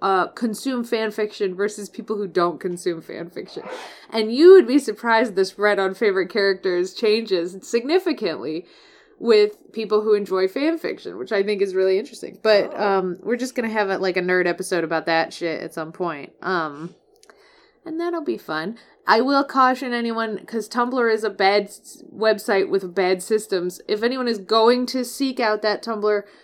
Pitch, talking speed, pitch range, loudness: 210 Hz, 175 wpm, 190-240 Hz, -21 LUFS